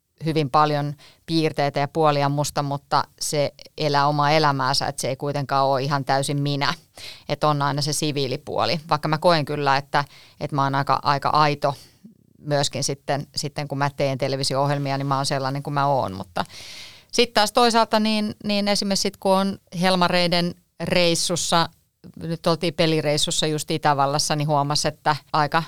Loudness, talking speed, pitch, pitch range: -22 LUFS, 165 wpm, 145 Hz, 140-165 Hz